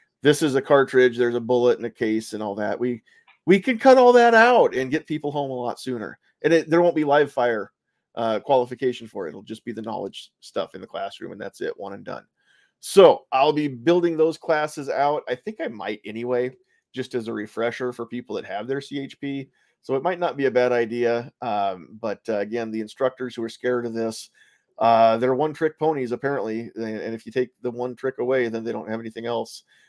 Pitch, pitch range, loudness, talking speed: 125 Hz, 115-145 Hz, -22 LUFS, 230 wpm